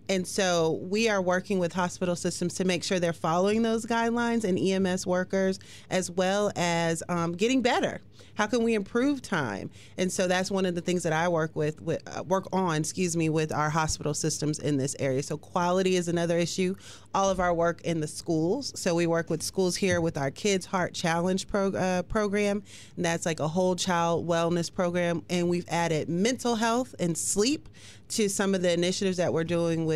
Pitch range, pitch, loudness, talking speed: 170-190 Hz, 180 Hz, -27 LUFS, 205 wpm